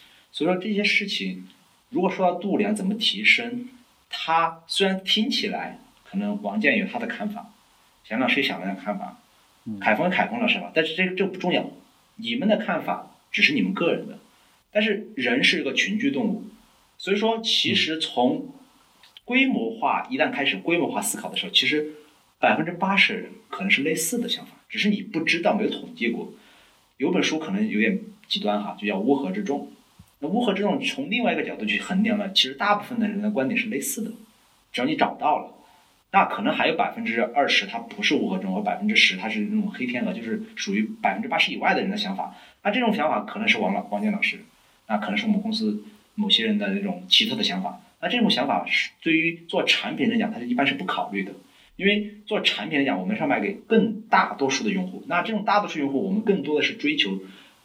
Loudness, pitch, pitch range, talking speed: -23 LUFS, 210 Hz, 190-225 Hz, 325 characters per minute